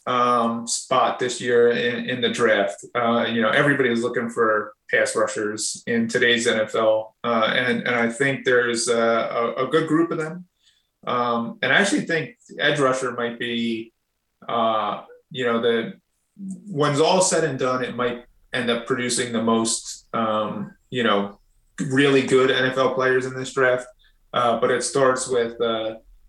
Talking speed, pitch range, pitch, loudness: 170 wpm, 115-130 Hz, 120 Hz, -21 LUFS